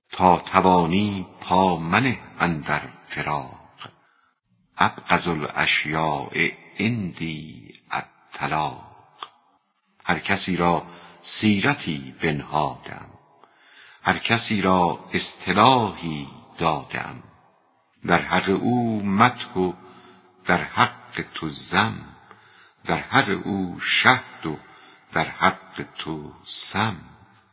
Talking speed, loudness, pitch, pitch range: 85 wpm, -23 LUFS, 90 Hz, 80-100 Hz